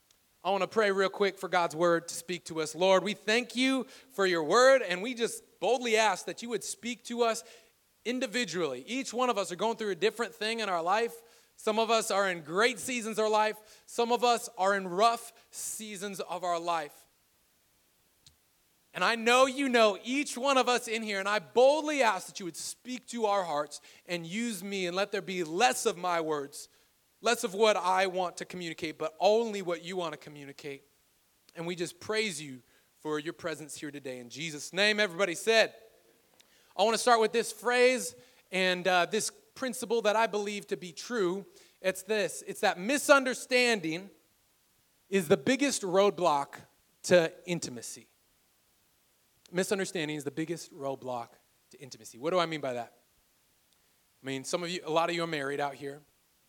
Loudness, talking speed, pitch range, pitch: -30 LUFS, 190 wpm, 170-230 Hz, 195 Hz